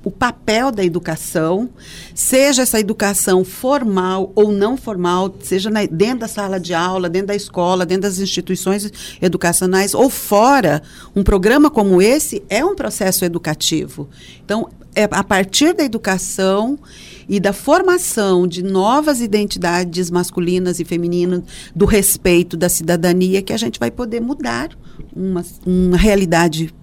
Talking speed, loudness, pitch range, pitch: 140 wpm, -16 LUFS, 180-215 Hz, 190 Hz